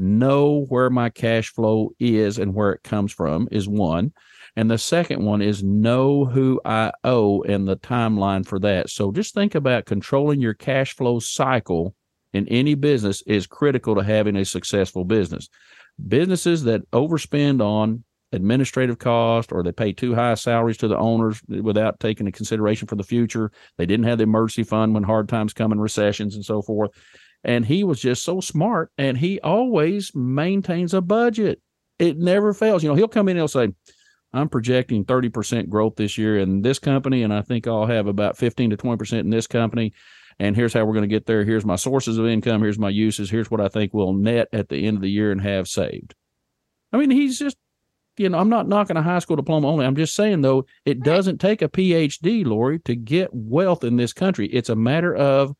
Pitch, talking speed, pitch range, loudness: 115 Hz, 205 wpm, 105-145 Hz, -21 LUFS